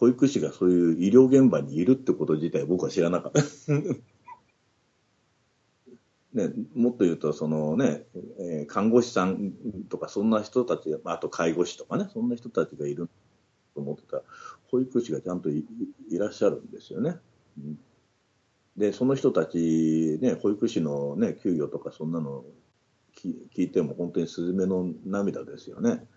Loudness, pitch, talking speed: -26 LUFS, 110 Hz, 295 characters per minute